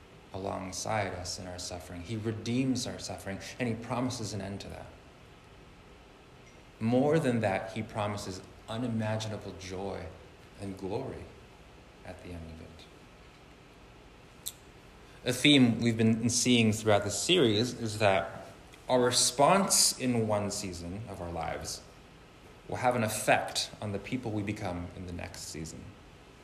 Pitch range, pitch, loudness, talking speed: 90-115 Hz, 100 Hz, -30 LUFS, 140 wpm